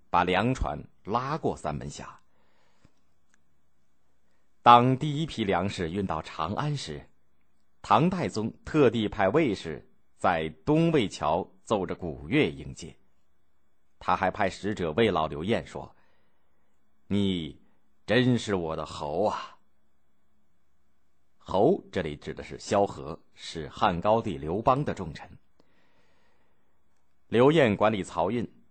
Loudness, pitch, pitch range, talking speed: -27 LUFS, 75 Hz, 70-100 Hz, 160 characters per minute